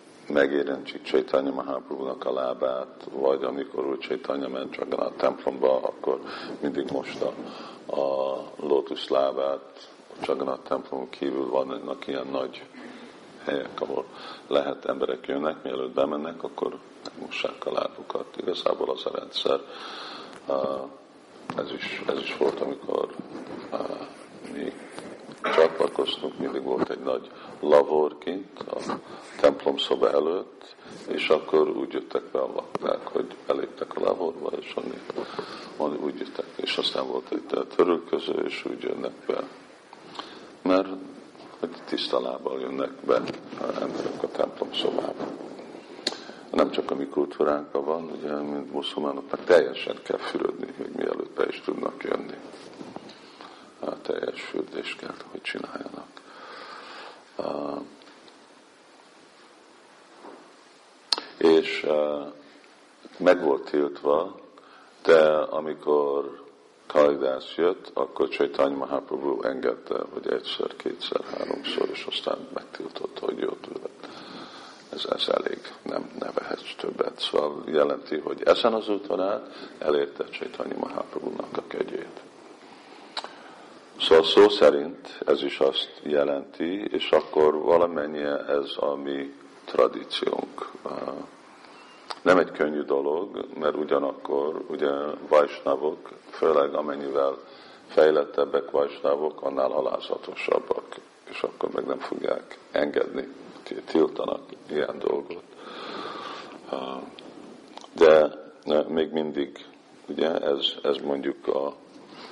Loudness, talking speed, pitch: -27 LUFS, 110 wpm, 390 Hz